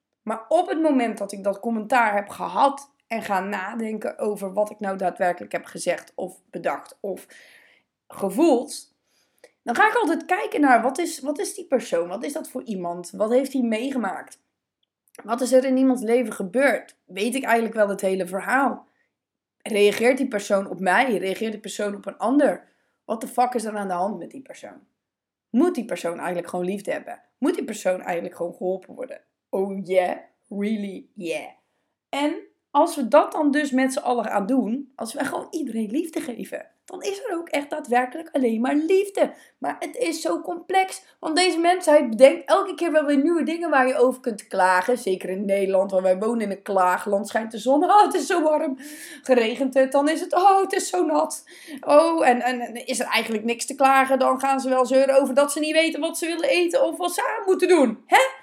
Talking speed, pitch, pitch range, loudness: 210 wpm, 255 Hz, 210-305 Hz, -22 LUFS